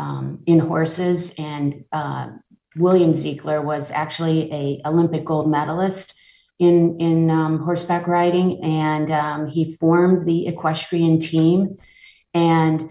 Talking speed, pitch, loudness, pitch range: 120 wpm, 165 Hz, -19 LUFS, 155-175 Hz